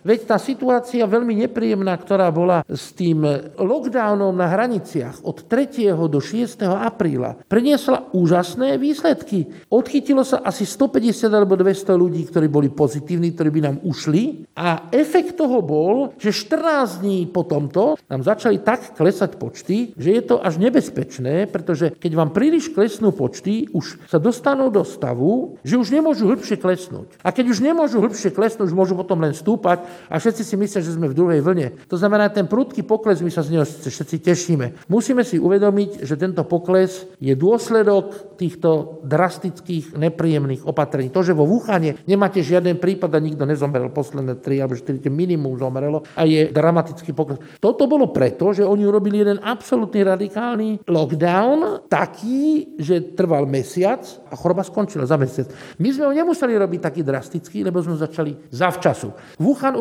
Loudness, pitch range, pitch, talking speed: -19 LUFS, 160-220 Hz, 185 Hz, 165 wpm